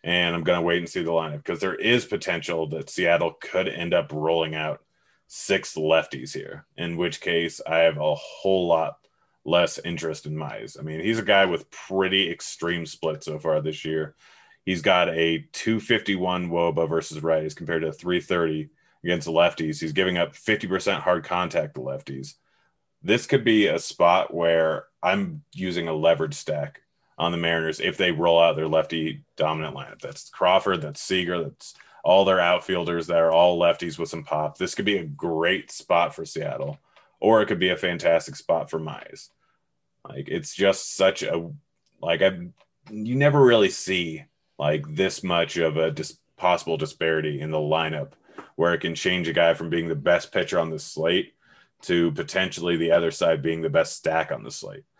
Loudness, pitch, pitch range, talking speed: -24 LUFS, 85 Hz, 80-90 Hz, 185 wpm